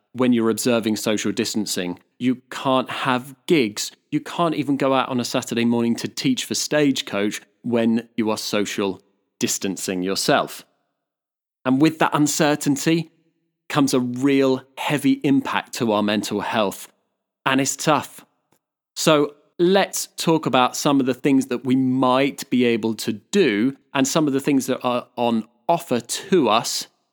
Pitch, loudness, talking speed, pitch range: 130 Hz, -21 LUFS, 155 wpm, 115-145 Hz